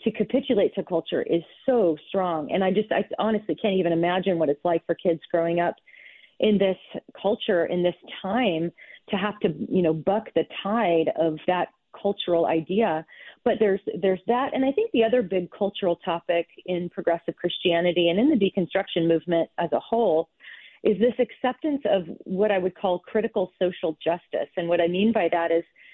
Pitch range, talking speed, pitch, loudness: 170-215 Hz, 185 wpm, 185 Hz, -25 LUFS